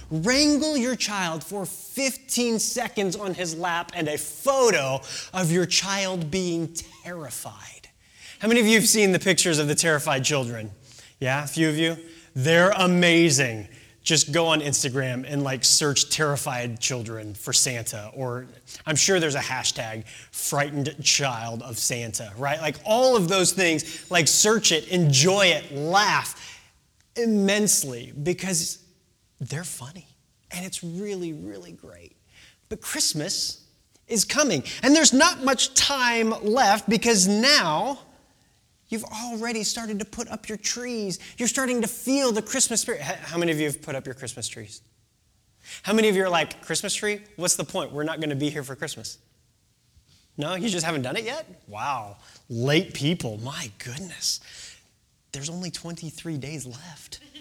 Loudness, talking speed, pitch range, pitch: -23 LUFS, 160 wpm, 135-205 Hz, 165 Hz